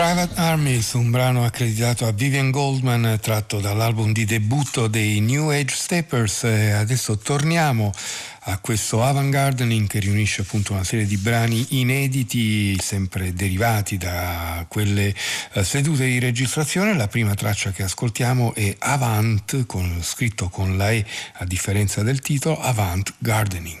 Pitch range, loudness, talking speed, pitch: 100-130 Hz, -21 LUFS, 135 wpm, 115 Hz